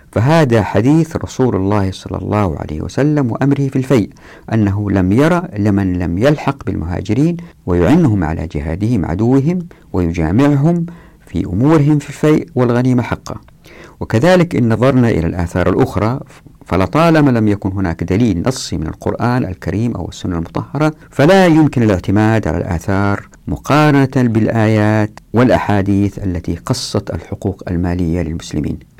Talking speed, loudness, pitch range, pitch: 125 wpm, -14 LUFS, 95-140 Hz, 110 Hz